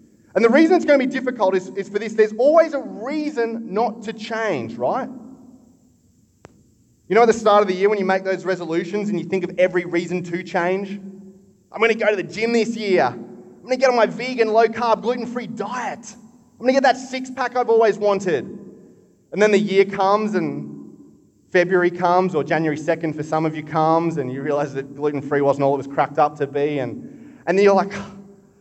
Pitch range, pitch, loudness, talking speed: 175-230 Hz, 200 Hz, -20 LUFS, 225 wpm